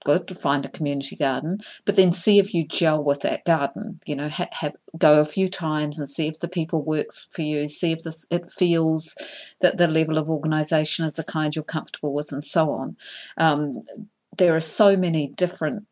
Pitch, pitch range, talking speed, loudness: 160 Hz, 150-175 Hz, 210 wpm, -23 LUFS